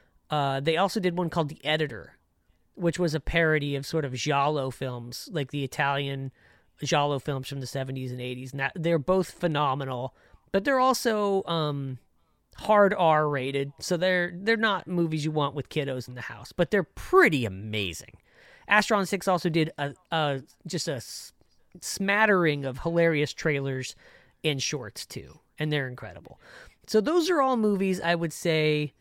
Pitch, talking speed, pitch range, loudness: 150 Hz, 165 wpm, 130-175 Hz, -27 LUFS